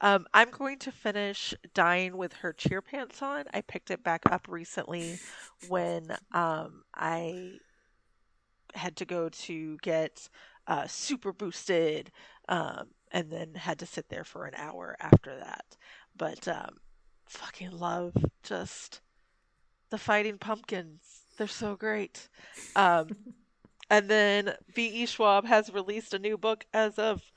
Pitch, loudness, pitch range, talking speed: 195 Hz, -30 LUFS, 170-215 Hz, 140 wpm